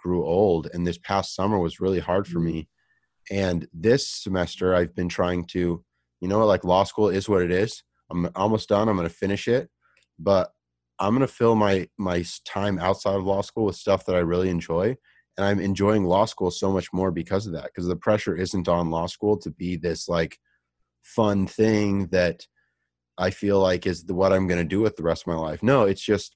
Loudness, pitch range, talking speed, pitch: -24 LUFS, 85-100 Hz, 220 wpm, 95 Hz